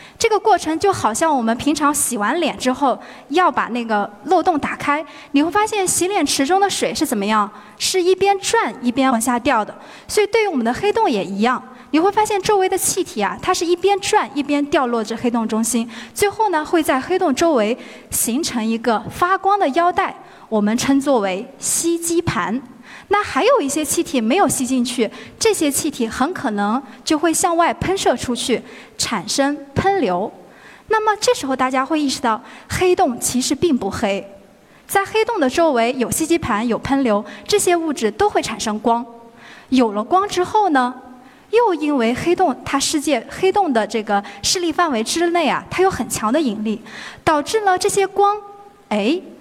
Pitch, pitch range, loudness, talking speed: 290 Hz, 235-370 Hz, -18 LUFS, 270 characters per minute